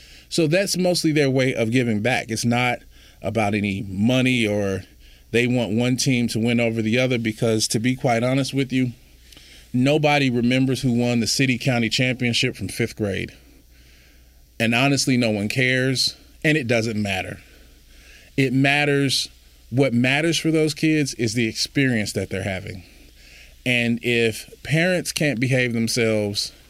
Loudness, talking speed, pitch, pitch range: -21 LUFS, 155 wpm, 120 Hz, 100-130 Hz